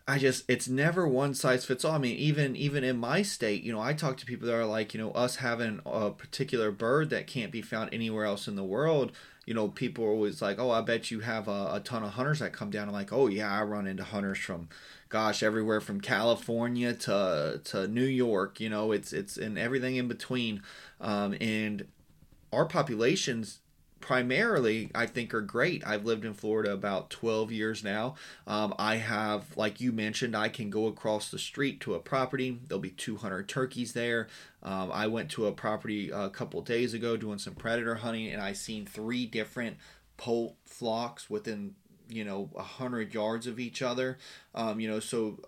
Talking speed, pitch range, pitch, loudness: 205 wpm, 105-125 Hz, 115 Hz, -32 LUFS